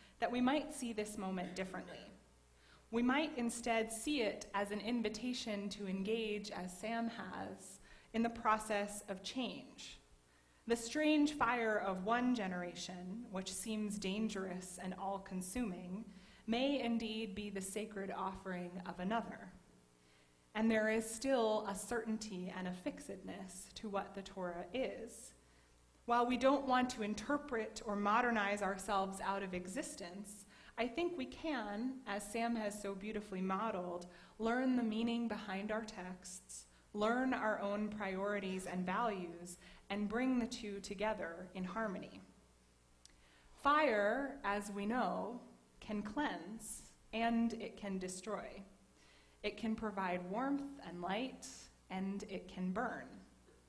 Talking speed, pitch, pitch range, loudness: 135 wpm, 210 Hz, 190-230 Hz, -40 LUFS